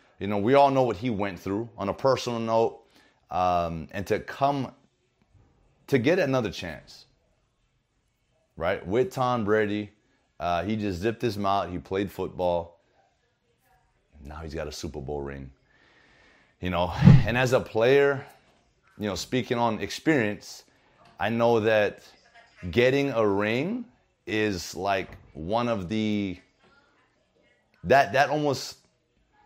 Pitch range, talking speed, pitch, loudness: 95-130 Hz, 135 wpm, 110 Hz, -26 LUFS